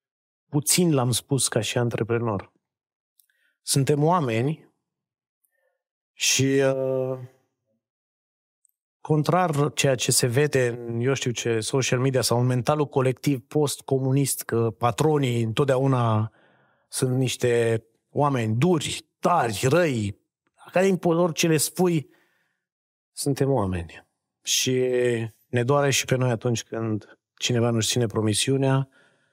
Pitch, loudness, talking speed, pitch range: 130 Hz, -23 LUFS, 115 wpm, 120-145 Hz